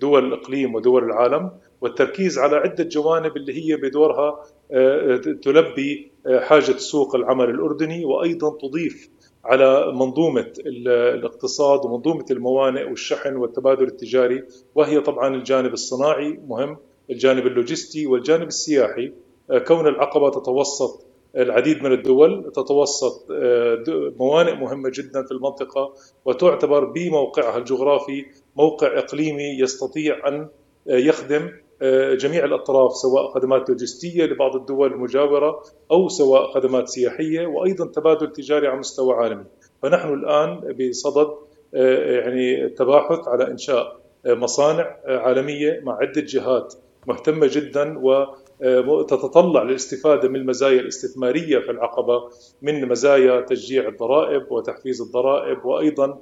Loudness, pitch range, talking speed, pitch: -20 LUFS, 130-170 Hz, 110 wpm, 145 Hz